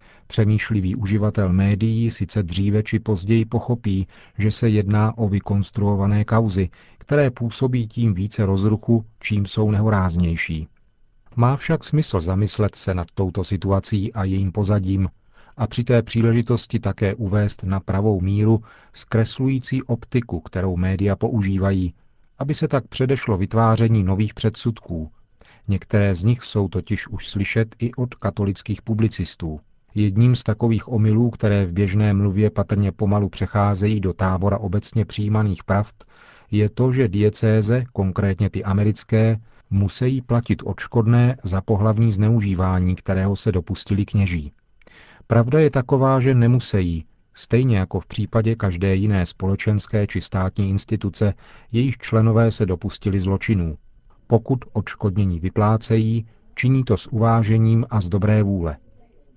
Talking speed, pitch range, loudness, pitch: 130 wpm, 100-115 Hz, -21 LUFS, 105 Hz